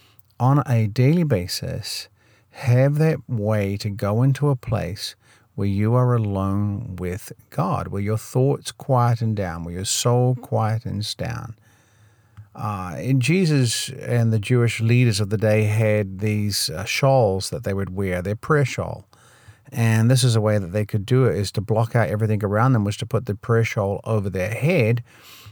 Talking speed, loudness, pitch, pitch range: 175 wpm, -21 LUFS, 110 Hz, 105-125 Hz